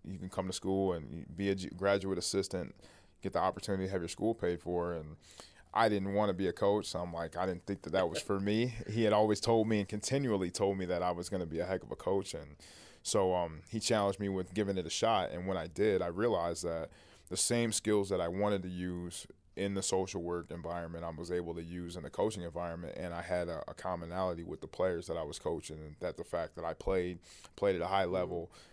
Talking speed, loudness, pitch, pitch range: 255 wpm, -35 LUFS, 90 Hz, 85-100 Hz